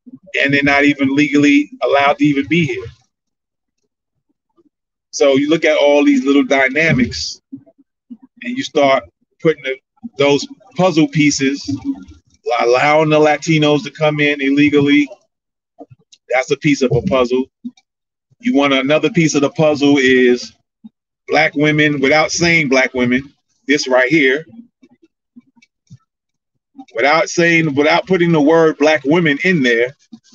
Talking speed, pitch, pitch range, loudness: 130 wpm, 150 Hz, 140-175 Hz, -14 LUFS